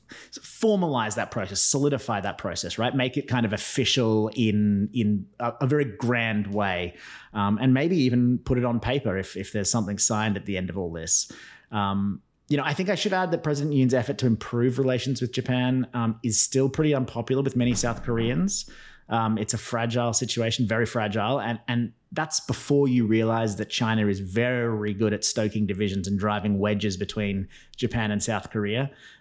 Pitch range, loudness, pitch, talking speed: 105-130 Hz, -25 LUFS, 115 Hz, 195 wpm